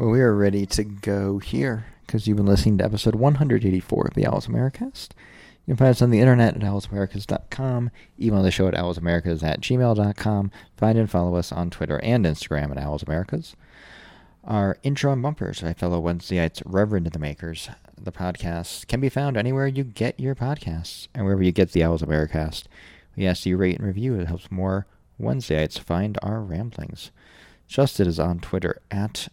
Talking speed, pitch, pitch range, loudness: 190 wpm, 100 Hz, 85-110 Hz, -23 LUFS